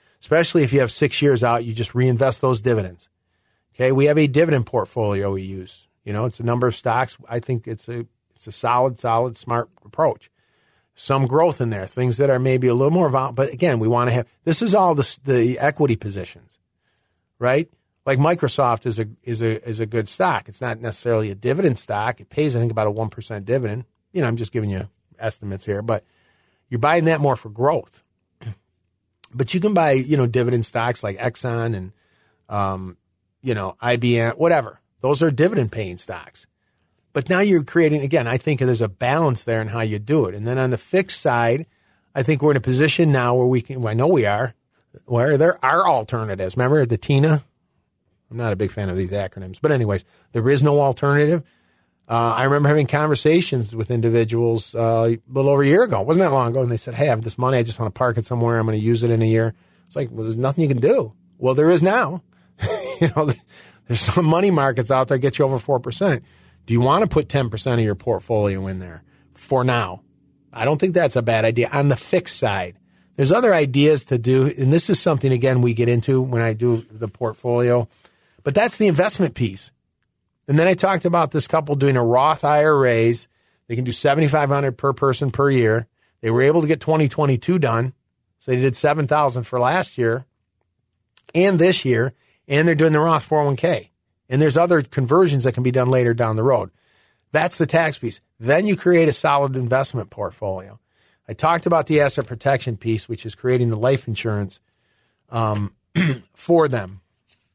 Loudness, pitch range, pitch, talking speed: -19 LUFS, 110-145 Hz, 125 Hz, 210 wpm